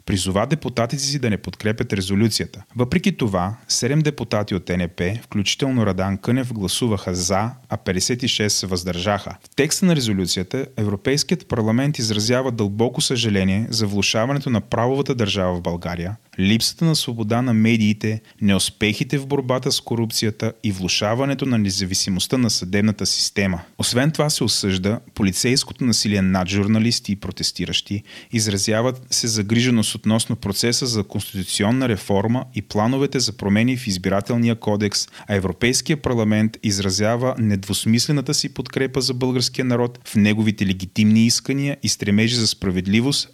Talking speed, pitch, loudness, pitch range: 135 wpm, 110 Hz, -20 LUFS, 100-125 Hz